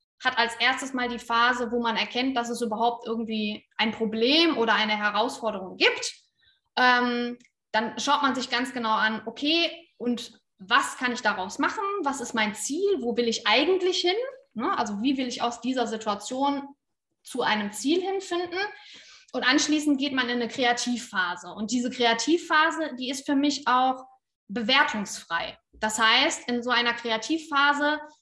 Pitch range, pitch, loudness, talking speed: 230-295 Hz, 245 Hz, -25 LUFS, 165 wpm